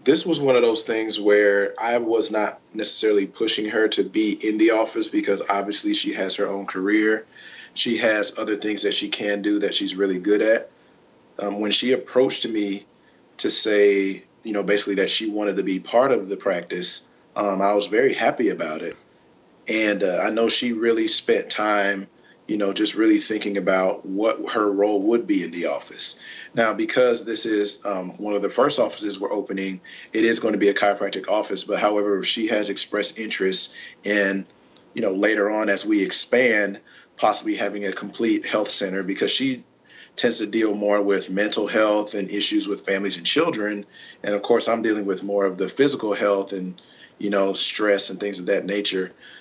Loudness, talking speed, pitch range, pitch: -21 LUFS, 195 wpm, 100-115 Hz, 105 Hz